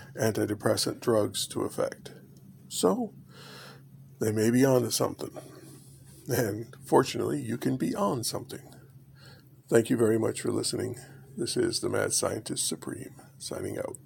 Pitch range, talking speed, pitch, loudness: 110-135 Hz, 135 wpm, 125 Hz, -29 LUFS